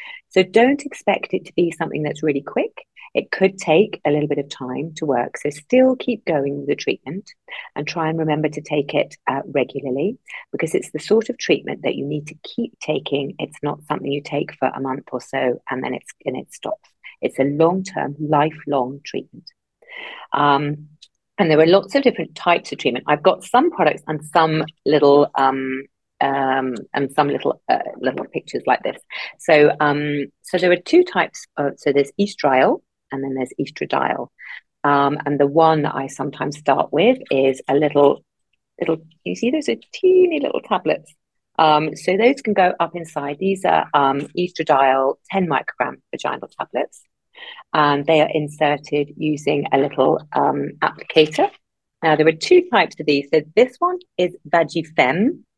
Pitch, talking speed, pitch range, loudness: 155 Hz, 180 wpm, 145-190 Hz, -19 LUFS